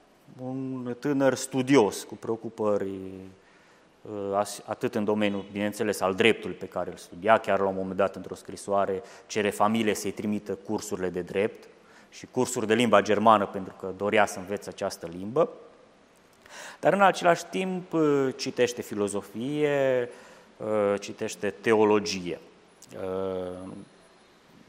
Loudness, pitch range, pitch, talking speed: -27 LUFS, 95-125 Hz, 105 Hz, 120 wpm